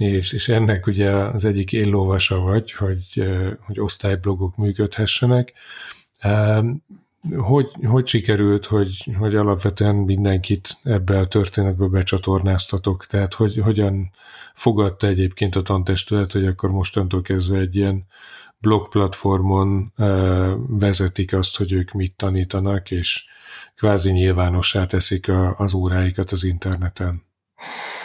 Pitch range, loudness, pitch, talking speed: 95-105 Hz, -20 LUFS, 100 Hz, 110 wpm